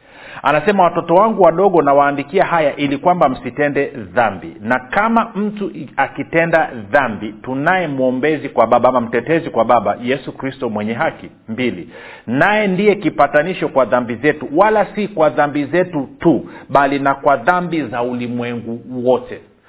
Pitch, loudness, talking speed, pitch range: 145 Hz, -16 LUFS, 140 wpm, 125-175 Hz